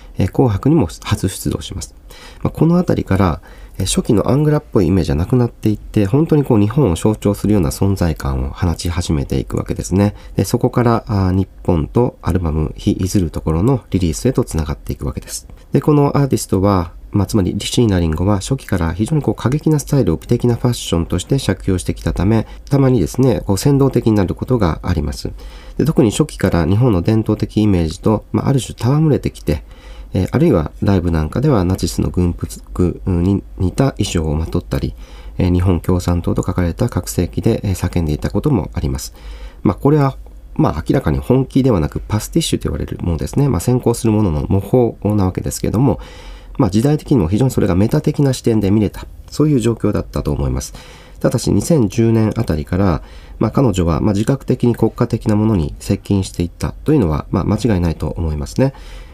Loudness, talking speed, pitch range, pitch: -16 LUFS, 415 characters per minute, 85-120 Hz, 100 Hz